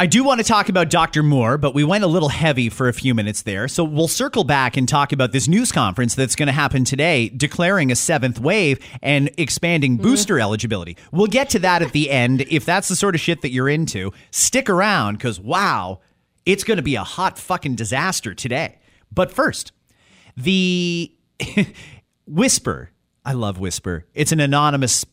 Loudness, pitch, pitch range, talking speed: -18 LUFS, 145 Hz, 125-175 Hz, 195 wpm